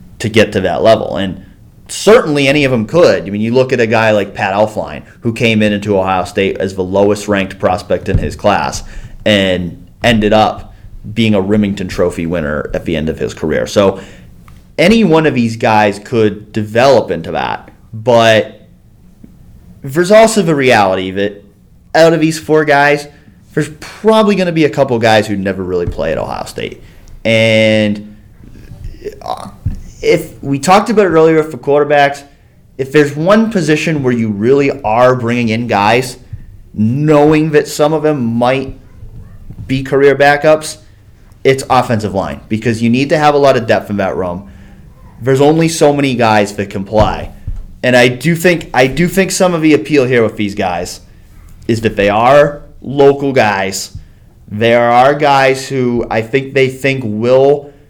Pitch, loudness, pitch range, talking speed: 120 Hz, -11 LUFS, 105-145 Hz, 175 wpm